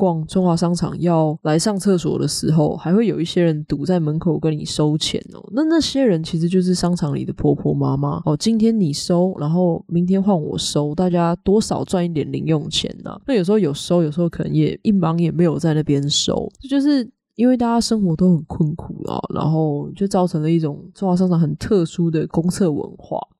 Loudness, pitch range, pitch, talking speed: -19 LUFS, 155-195 Hz, 175 Hz, 310 characters per minute